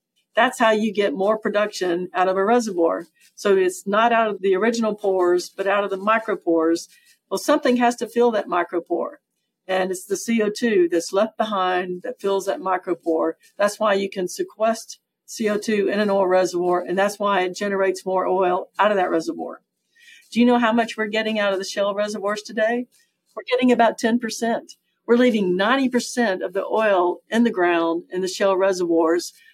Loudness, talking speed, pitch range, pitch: -21 LUFS, 185 wpm, 185-225 Hz, 205 Hz